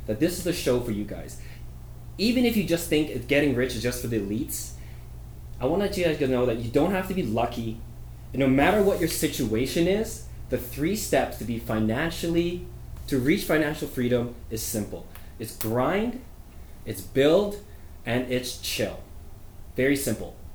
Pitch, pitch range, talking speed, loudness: 125 Hz, 105-160 Hz, 180 wpm, -26 LUFS